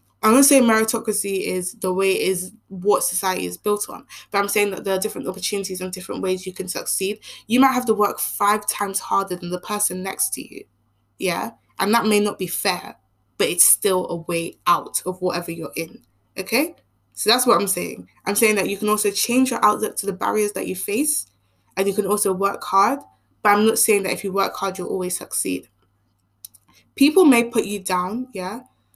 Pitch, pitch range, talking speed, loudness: 195 Hz, 185-215 Hz, 220 wpm, -20 LUFS